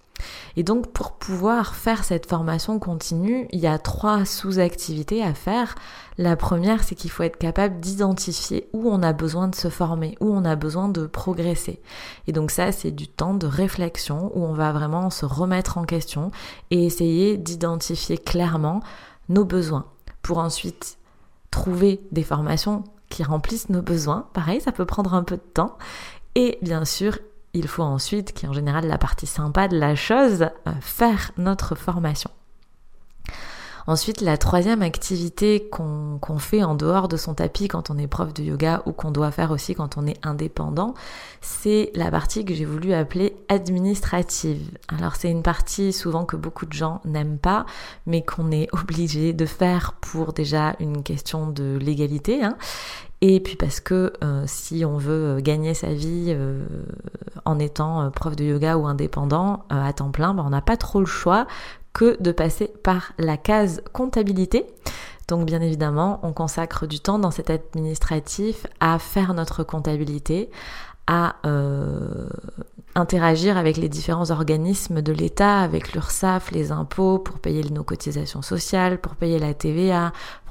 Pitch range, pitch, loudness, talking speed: 155-190 Hz, 170 Hz, -23 LUFS, 170 wpm